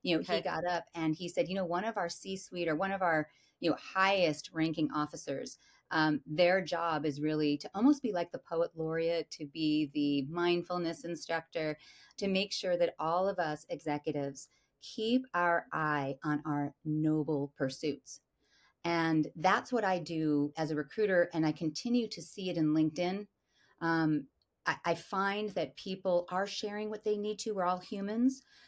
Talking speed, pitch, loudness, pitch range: 180 wpm, 170 Hz, -33 LUFS, 155-190 Hz